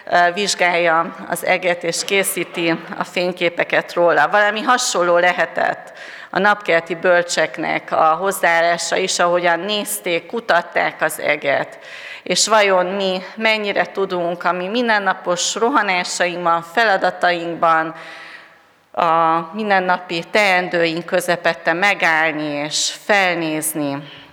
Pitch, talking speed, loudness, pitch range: 175 Hz, 95 wpm, -17 LUFS, 165-190 Hz